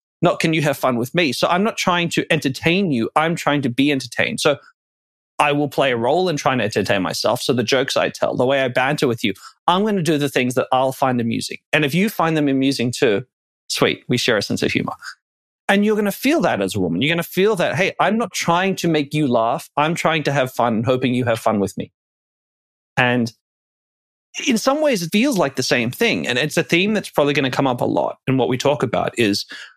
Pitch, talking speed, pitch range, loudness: 145 Hz, 255 wpm, 125-175 Hz, -19 LUFS